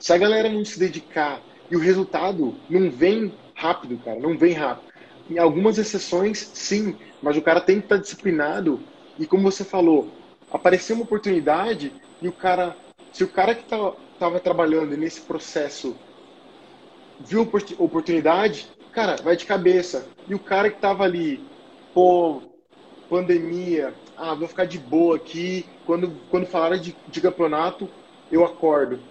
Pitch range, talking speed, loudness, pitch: 165-200 Hz, 155 wpm, -22 LUFS, 180 Hz